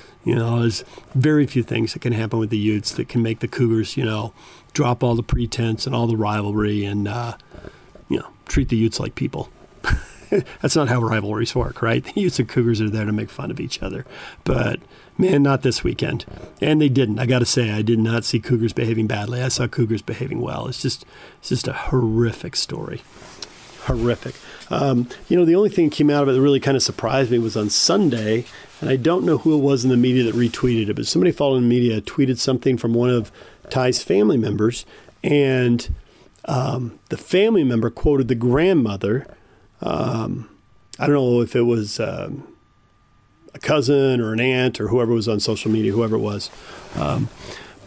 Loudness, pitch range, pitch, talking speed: -20 LUFS, 110-130 Hz, 120 Hz, 205 wpm